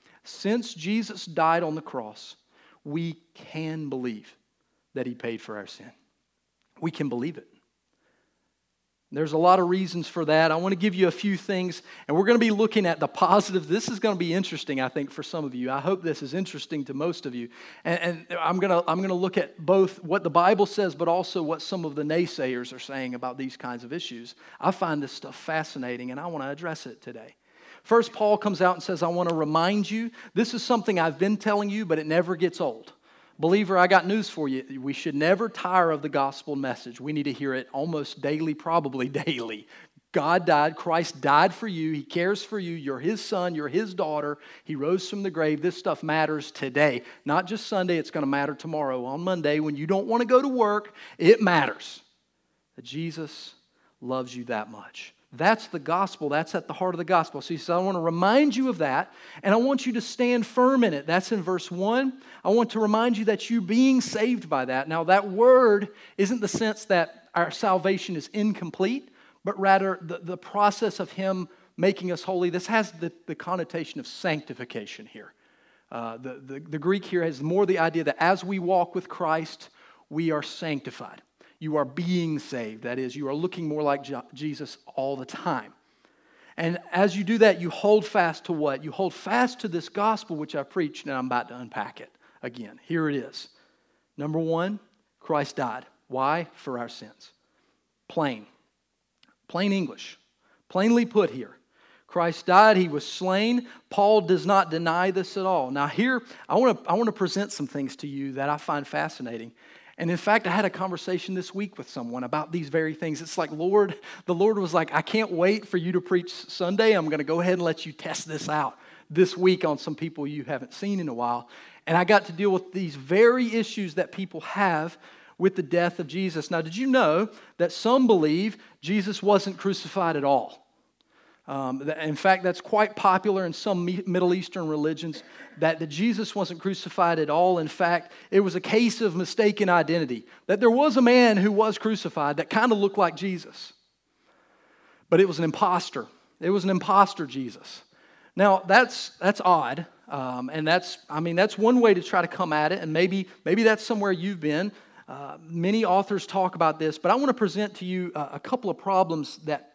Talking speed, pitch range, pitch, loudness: 210 wpm, 155-200 Hz, 175 Hz, -25 LUFS